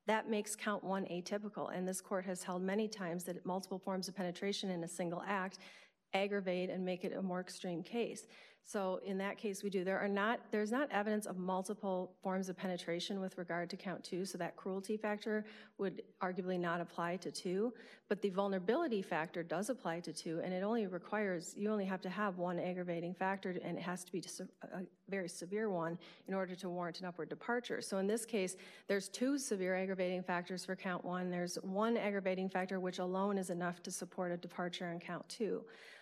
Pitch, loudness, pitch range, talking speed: 185 Hz, -40 LUFS, 180-200 Hz, 205 wpm